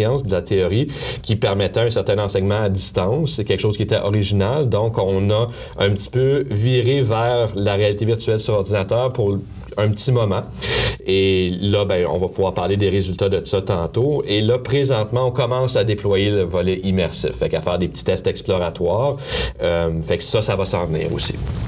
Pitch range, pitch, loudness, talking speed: 95-120 Hz, 105 Hz, -19 LUFS, 195 wpm